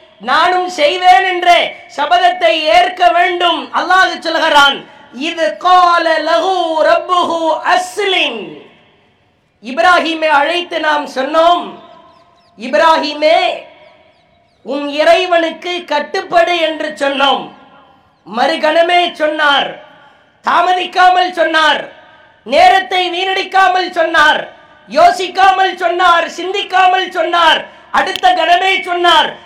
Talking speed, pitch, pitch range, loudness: 75 wpm, 335 Hz, 315-360 Hz, -11 LUFS